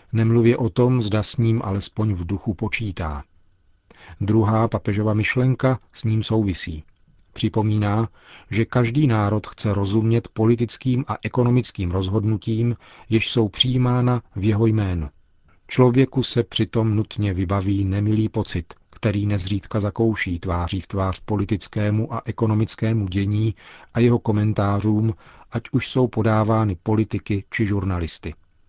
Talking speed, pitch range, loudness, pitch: 125 wpm, 100-115 Hz, -22 LUFS, 110 Hz